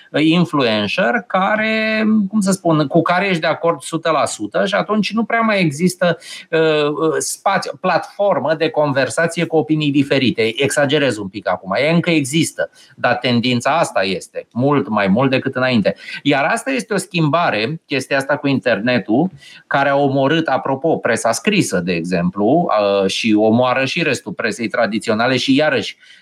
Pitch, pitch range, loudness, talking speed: 160 Hz, 135-180 Hz, -16 LUFS, 155 wpm